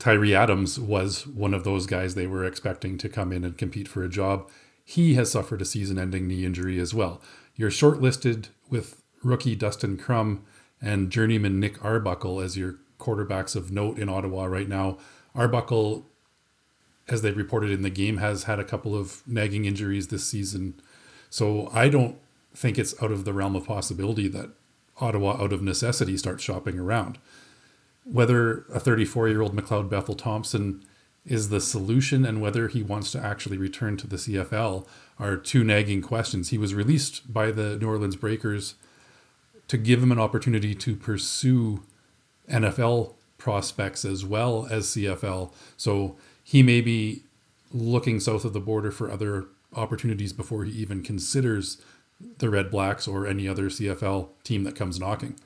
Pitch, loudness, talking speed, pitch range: 105 Hz, -26 LUFS, 170 wpm, 95-115 Hz